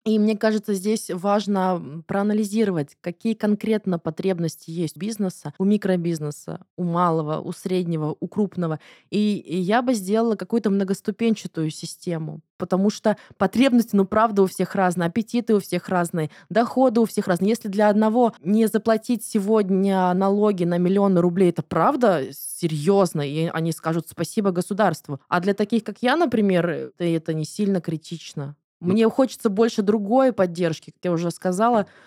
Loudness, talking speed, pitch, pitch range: -22 LUFS, 150 wpm, 190 Hz, 170-215 Hz